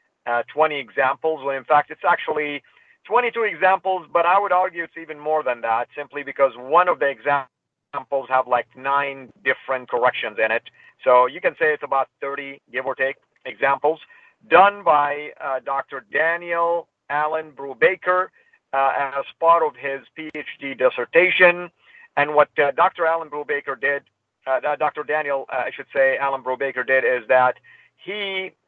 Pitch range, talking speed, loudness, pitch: 135-165 Hz, 165 wpm, -21 LUFS, 145 Hz